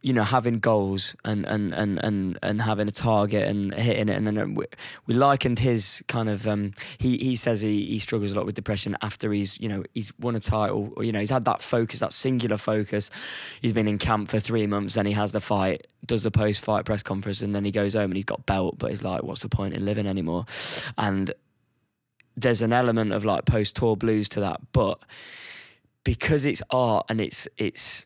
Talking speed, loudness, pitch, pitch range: 225 wpm, -25 LUFS, 105 Hz, 100-115 Hz